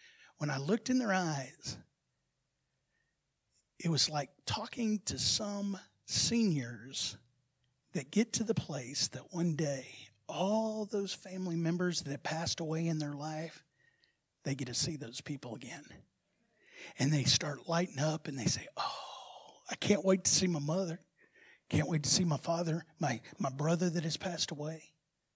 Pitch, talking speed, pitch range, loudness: 160 Hz, 160 wpm, 140-185 Hz, -34 LUFS